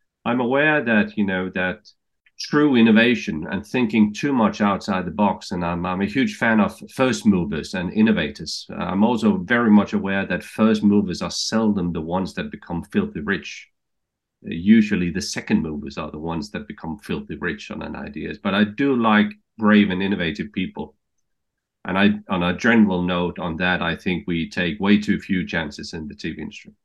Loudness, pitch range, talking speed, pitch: -21 LUFS, 90-120 Hz, 190 wpm, 105 Hz